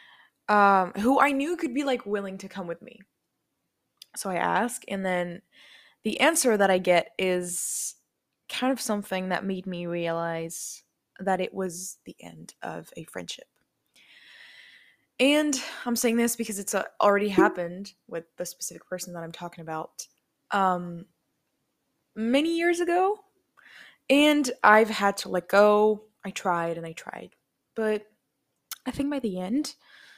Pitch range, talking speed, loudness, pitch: 180-260 Hz, 150 wpm, -26 LUFS, 205 Hz